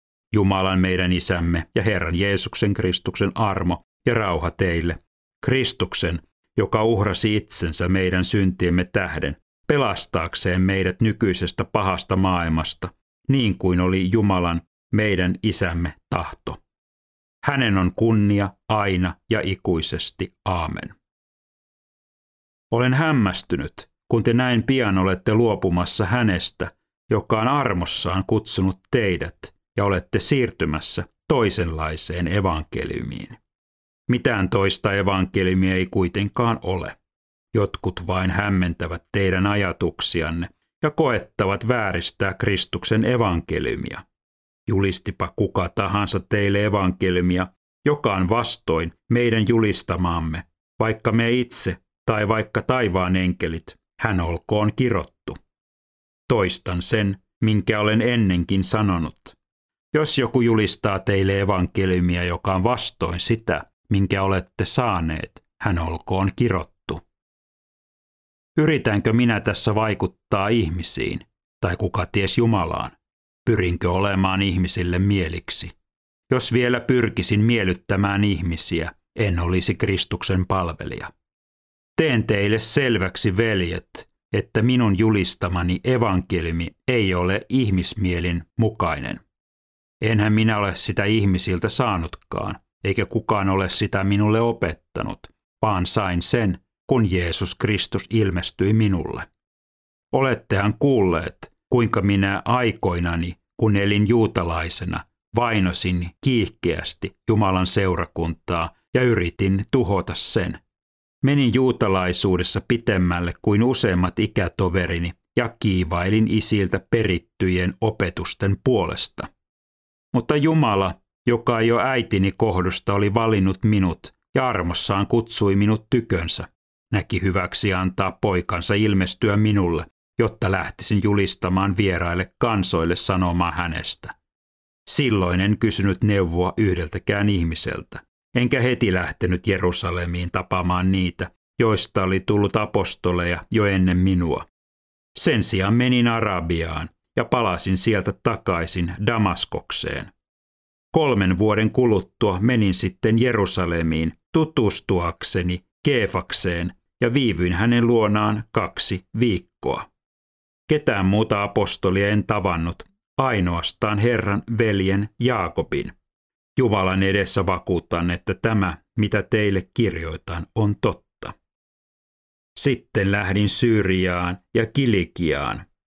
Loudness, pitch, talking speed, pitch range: -22 LUFS, 95 Hz, 100 wpm, 90-110 Hz